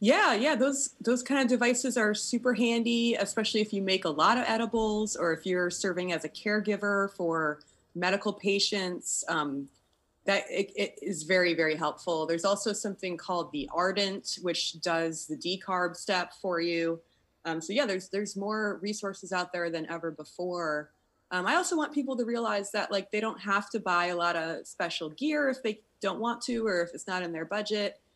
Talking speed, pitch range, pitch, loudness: 195 wpm, 170-220 Hz, 195 Hz, -30 LUFS